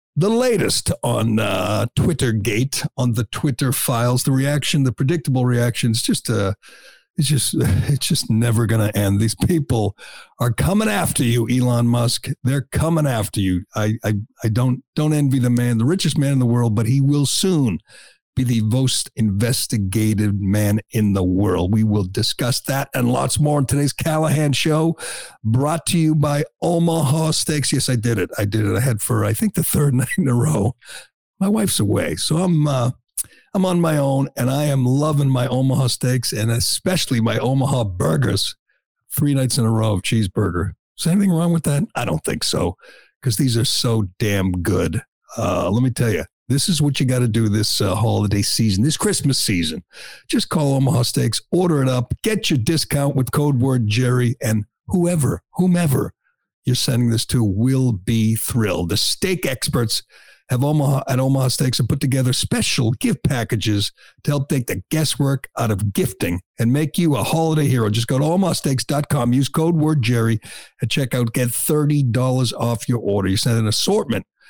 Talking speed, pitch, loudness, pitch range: 190 wpm, 130 Hz, -19 LUFS, 115-145 Hz